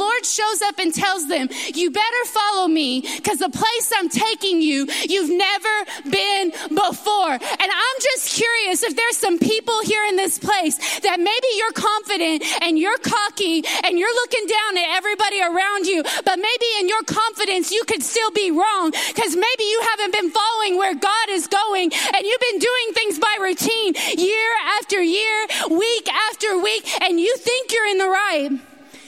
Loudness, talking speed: -19 LUFS, 180 wpm